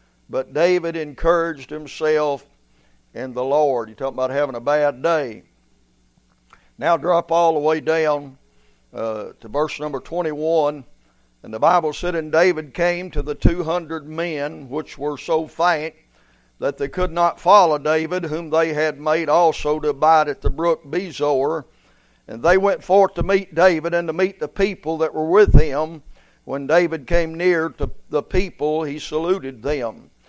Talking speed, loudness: 165 wpm, -20 LUFS